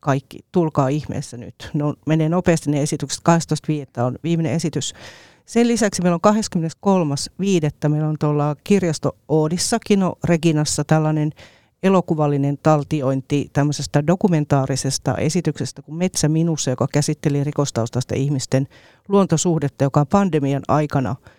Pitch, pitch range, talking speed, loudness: 150 Hz, 140-170 Hz, 125 wpm, -20 LUFS